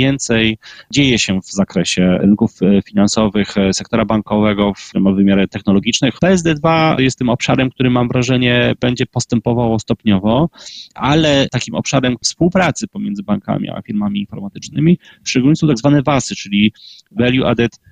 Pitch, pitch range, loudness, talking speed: 120 Hz, 105-145 Hz, -15 LUFS, 130 wpm